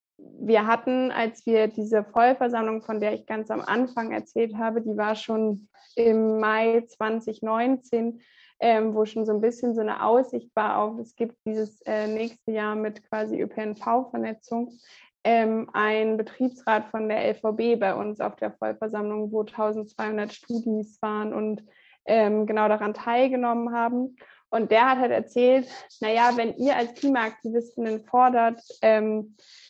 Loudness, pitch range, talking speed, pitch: -25 LUFS, 215-235 Hz, 150 wpm, 225 Hz